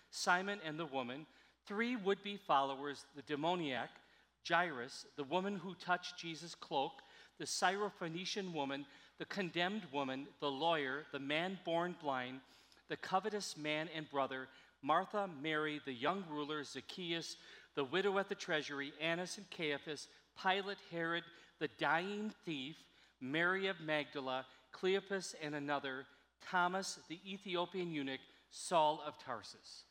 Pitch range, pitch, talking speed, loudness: 145-185 Hz, 165 Hz, 130 wpm, -40 LUFS